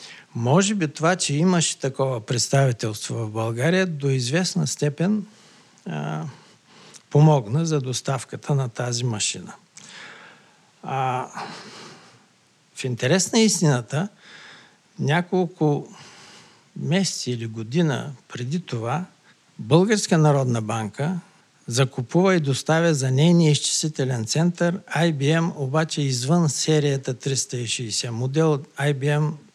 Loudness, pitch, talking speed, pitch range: -22 LUFS, 145 Hz, 95 wpm, 130-170 Hz